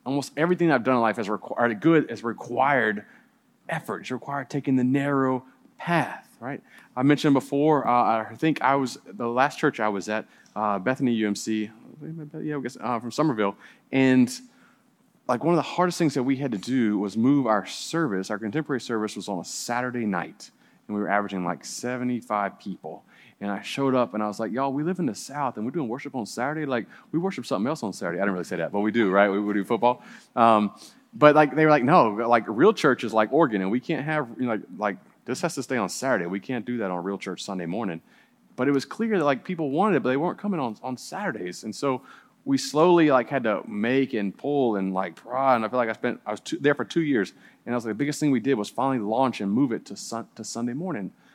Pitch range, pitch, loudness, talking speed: 110-145 Hz, 125 Hz, -25 LUFS, 245 wpm